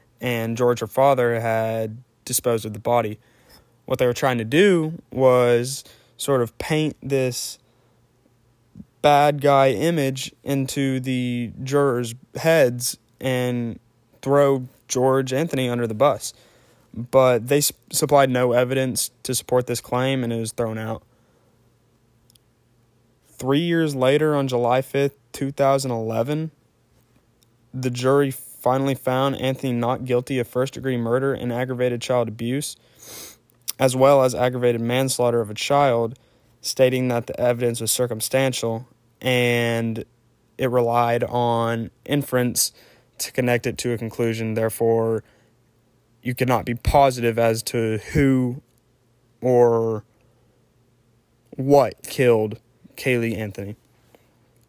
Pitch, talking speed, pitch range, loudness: 125 Hz, 115 wpm, 115-130 Hz, -21 LUFS